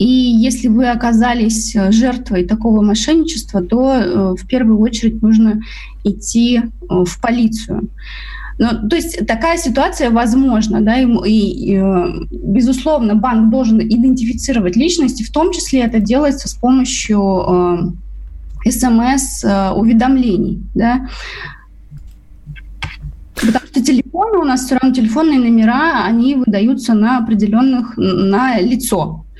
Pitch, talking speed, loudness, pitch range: 230 Hz, 120 wpm, -13 LUFS, 205-255 Hz